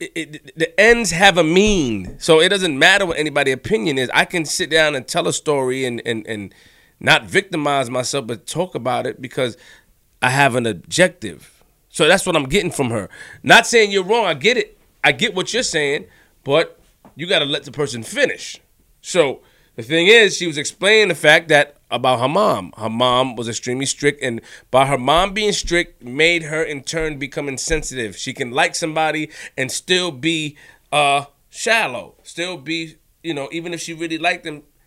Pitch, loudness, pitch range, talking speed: 155 Hz, -17 LUFS, 130-170 Hz, 195 wpm